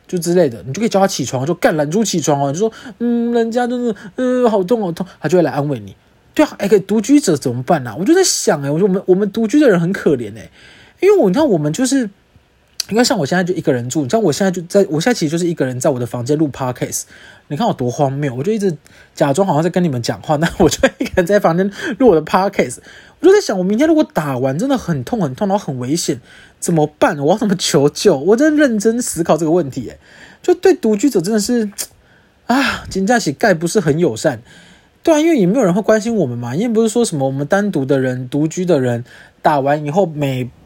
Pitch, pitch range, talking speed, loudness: 185 Hz, 150-225 Hz, 380 characters per minute, -15 LUFS